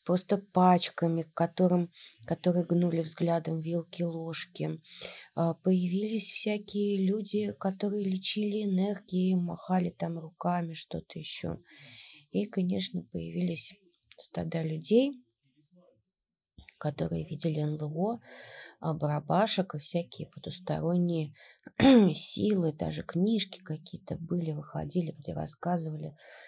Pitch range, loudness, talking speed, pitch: 160-190 Hz, -30 LUFS, 85 wpm, 175 Hz